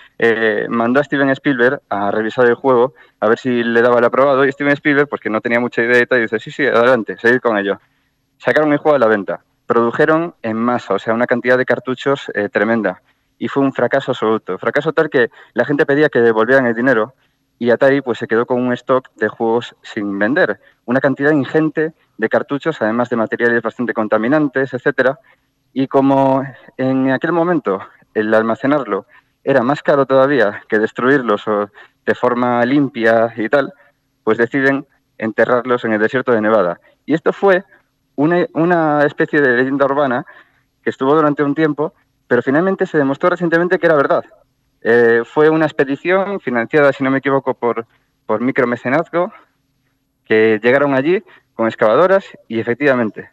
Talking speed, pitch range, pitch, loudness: 175 wpm, 115-145 Hz, 130 Hz, -15 LUFS